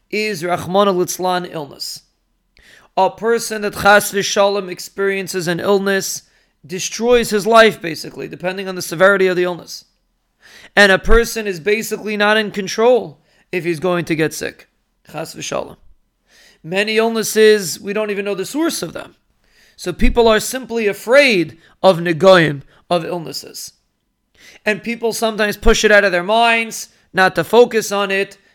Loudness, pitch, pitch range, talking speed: -16 LUFS, 200 Hz, 180-220 Hz, 150 wpm